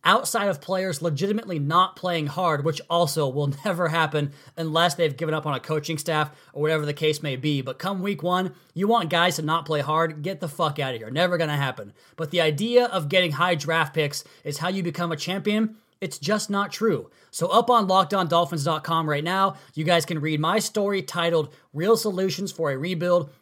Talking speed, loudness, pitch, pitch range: 215 wpm, -24 LUFS, 170 Hz, 155-190 Hz